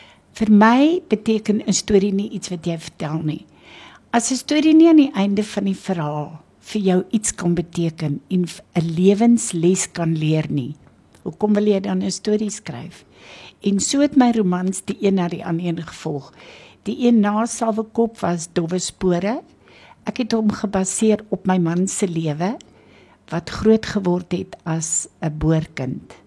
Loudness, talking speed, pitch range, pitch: -19 LUFS, 165 wpm, 170-215 Hz, 195 Hz